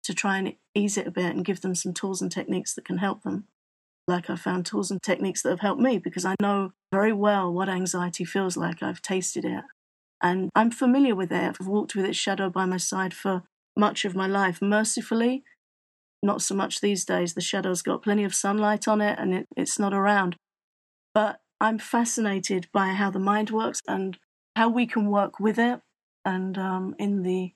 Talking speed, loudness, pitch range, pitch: 210 wpm, -26 LUFS, 185-210 Hz, 195 Hz